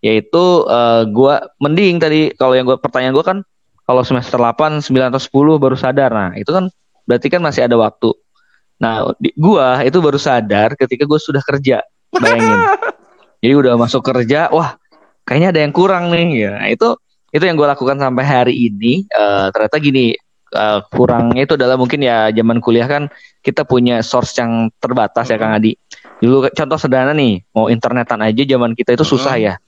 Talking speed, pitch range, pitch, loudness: 185 wpm, 120-145 Hz, 130 Hz, -13 LUFS